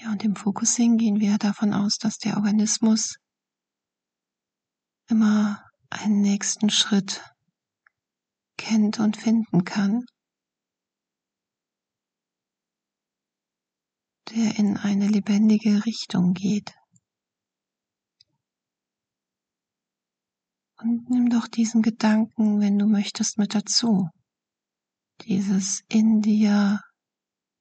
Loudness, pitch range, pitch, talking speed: -22 LUFS, 205-225 Hz, 210 Hz, 85 wpm